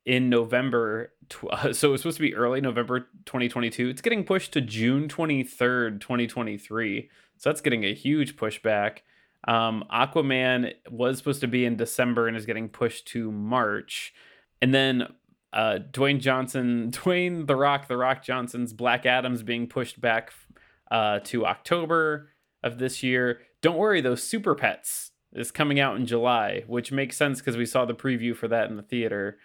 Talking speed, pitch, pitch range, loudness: 165 wpm, 125 Hz, 120-135 Hz, -26 LUFS